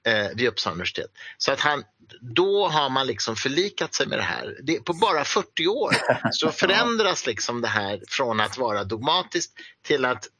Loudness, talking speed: -23 LUFS, 180 wpm